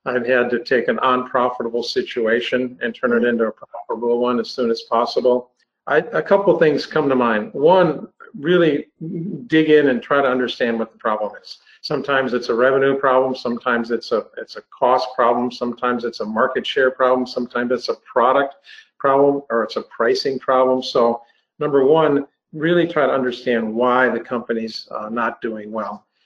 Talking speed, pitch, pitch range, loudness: 185 wpm, 125 Hz, 120-140 Hz, -19 LUFS